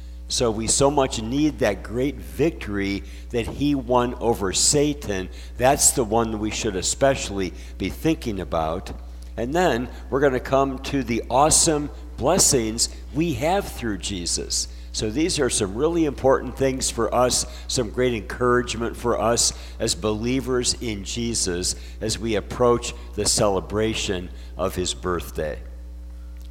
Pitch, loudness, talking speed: 110 Hz, -22 LUFS, 145 wpm